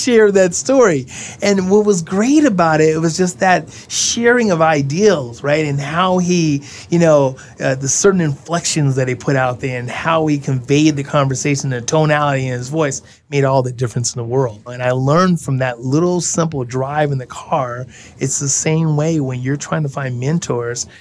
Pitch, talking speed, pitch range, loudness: 145 Hz, 200 wpm, 130-165 Hz, -16 LUFS